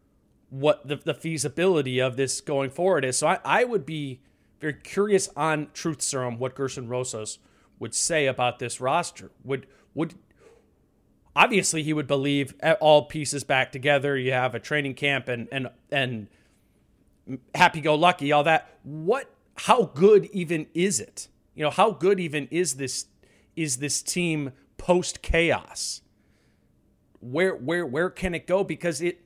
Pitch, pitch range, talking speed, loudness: 150 Hz, 135-170 Hz, 155 wpm, -25 LUFS